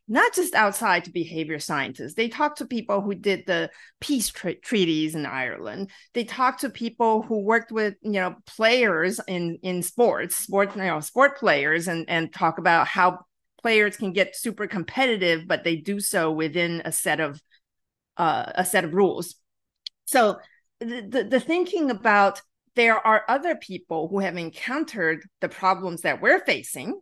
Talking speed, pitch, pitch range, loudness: 170 wpm, 200 Hz, 170-230 Hz, -23 LUFS